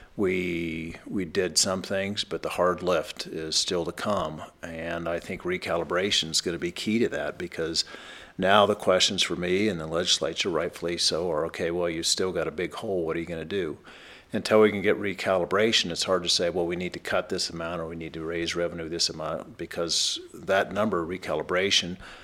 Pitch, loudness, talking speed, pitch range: 85 Hz, -26 LUFS, 215 wpm, 80-90 Hz